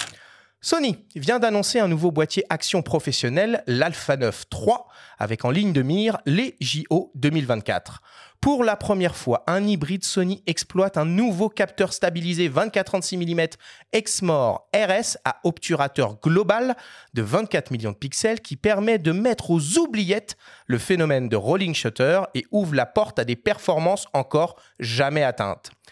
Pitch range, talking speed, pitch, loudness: 145-205 Hz, 150 wpm, 175 Hz, -23 LUFS